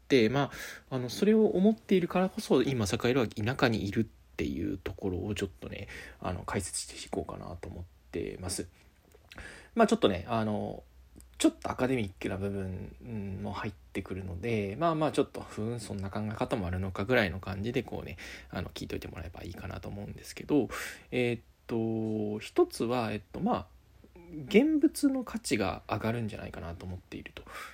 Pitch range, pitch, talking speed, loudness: 95-130 Hz, 105 Hz, 385 characters per minute, -32 LUFS